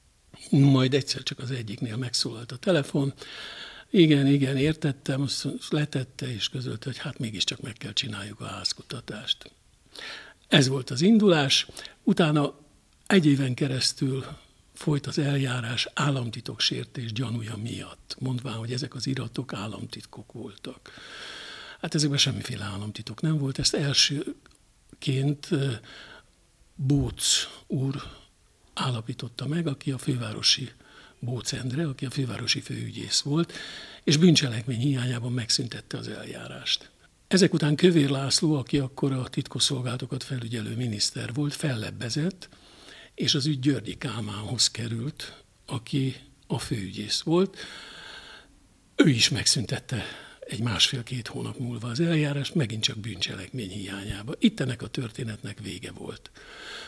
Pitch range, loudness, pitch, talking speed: 120-145 Hz, -26 LUFS, 135 Hz, 120 wpm